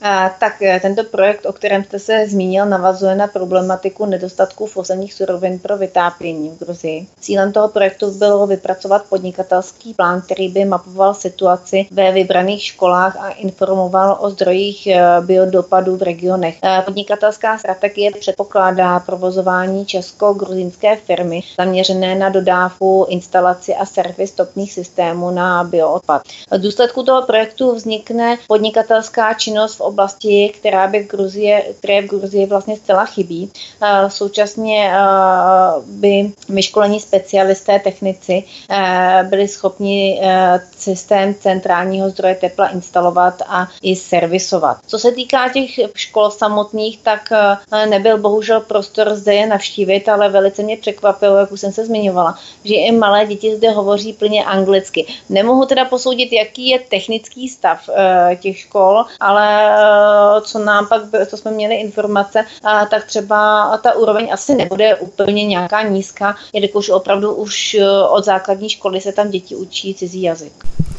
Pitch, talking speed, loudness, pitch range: 200 Hz, 135 wpm, -14 LUFS, 185-210 Hz